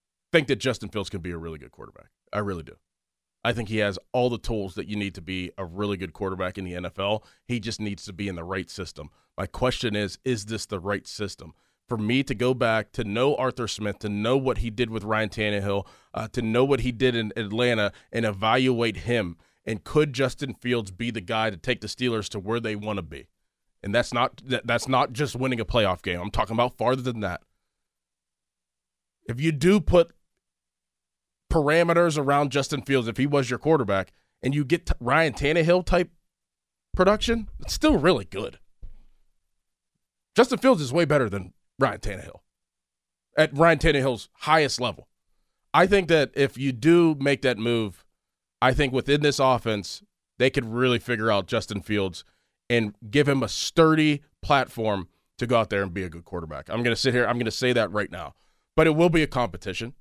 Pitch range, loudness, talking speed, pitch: 100-135 Hz, -25 LUFS, 200 wpm, 115 Hz